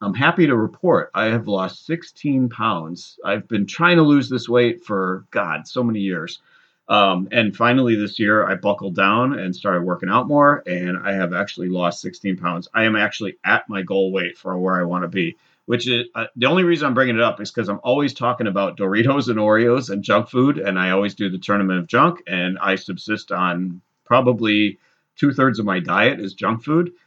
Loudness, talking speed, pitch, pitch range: -19 LUFS, 215 wpm, 105 Hz, 95-125 Hz